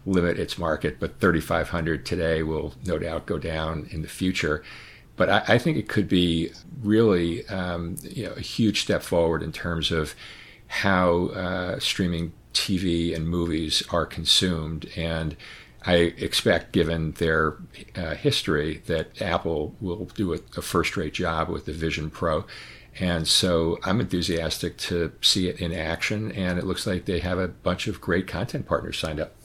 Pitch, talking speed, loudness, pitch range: 85 Hz, 165 wpm, -25 LUFS, 80-95 Hz